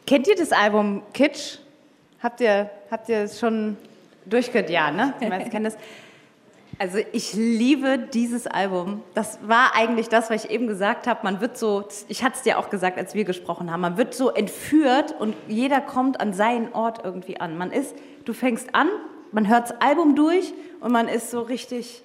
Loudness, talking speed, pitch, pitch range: -23 LUFS, 190 wpm, 230 Hz, 210-260 Hz